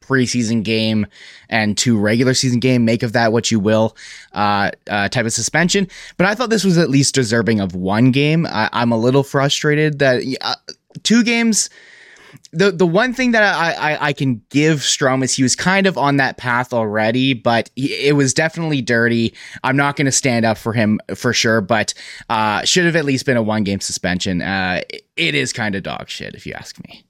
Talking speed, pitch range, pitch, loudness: 210 wpm, 115-155 Hz, 130 Hz, -16 LUFS